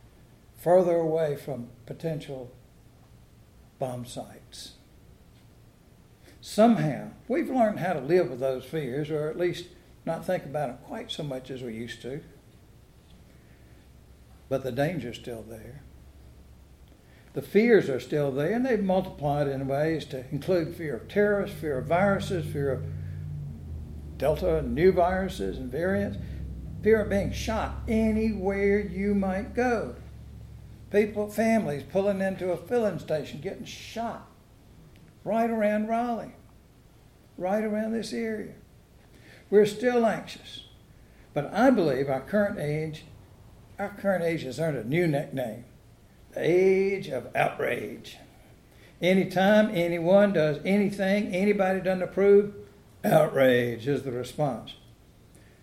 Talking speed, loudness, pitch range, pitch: 125 wpm, -27 LUFS, 120-200 Hz, 155 Hz